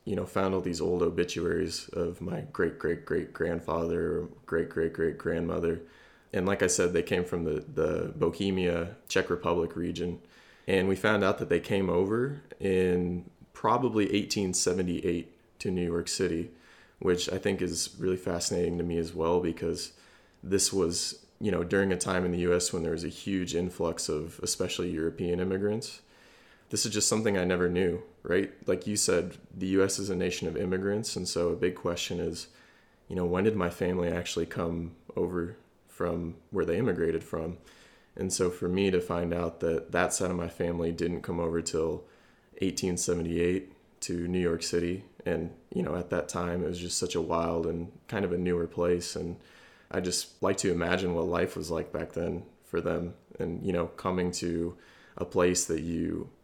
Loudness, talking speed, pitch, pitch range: -30 LUFS, 190 wpm, 90 Hz, 85-95 Hz